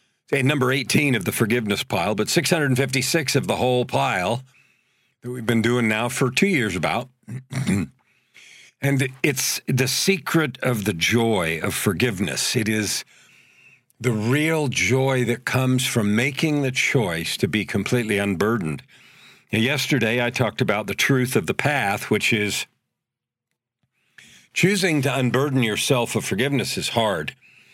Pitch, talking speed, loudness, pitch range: 125 Hz, 145 wpm, -21 LUFS, 115-135 Hz